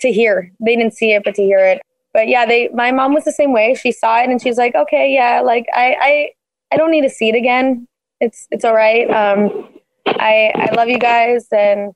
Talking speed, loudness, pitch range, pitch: 245 wpm, -13 LUFS, 220-255 Hz, 235 Hz